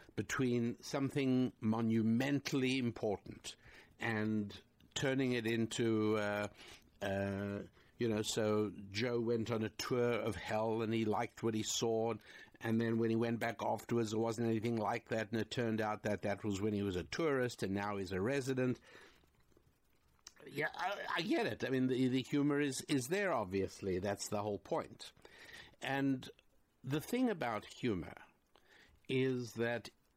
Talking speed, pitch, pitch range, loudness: 160 wpm, 115 Hz, 105-125 Hz, -38 LUFS